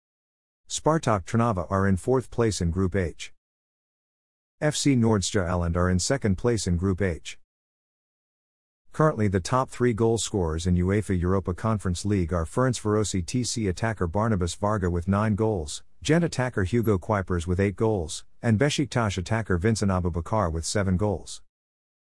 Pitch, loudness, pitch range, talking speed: 100 Hz, -25 LUFS, 90-115 Hz, 145 wpm